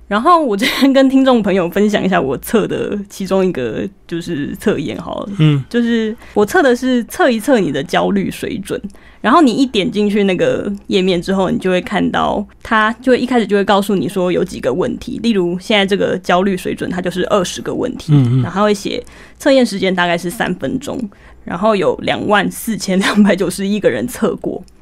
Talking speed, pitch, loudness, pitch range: 305 characters per minute, 205 Hz, -15 LUFS, 185-245 Hz